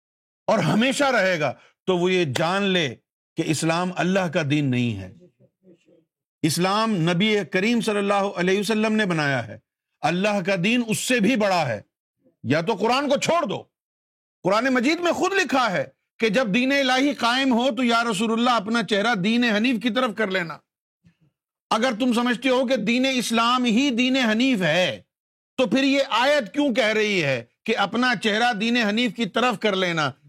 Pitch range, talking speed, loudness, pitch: 175-250 Hz, 180 wpm, -21 LUFS, 215 Hz